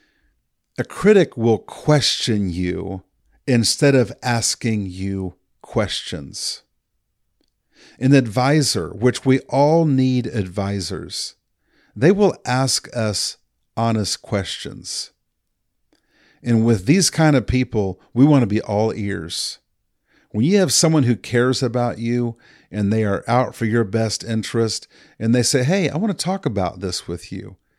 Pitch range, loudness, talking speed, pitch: 105-135 Hz, -19 LUFS, 135 wpm, 115 Hz